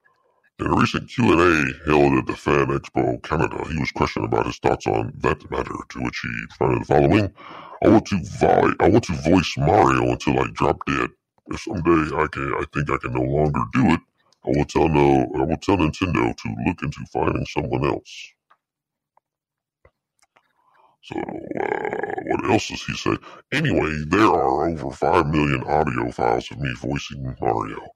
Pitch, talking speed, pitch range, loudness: 75 Hz, 180 wpm, 70-85 Hz, -21 LUFS